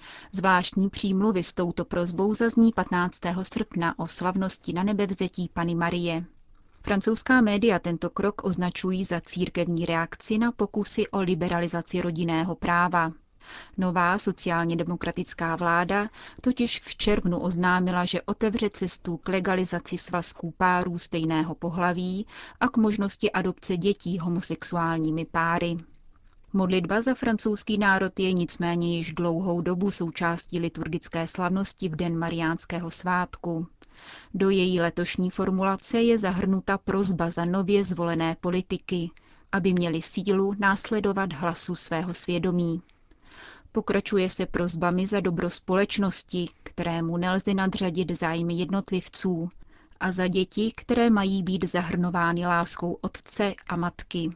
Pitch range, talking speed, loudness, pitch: 170-195 Hz, 120 wpm, -26 LUFS, 180 Hz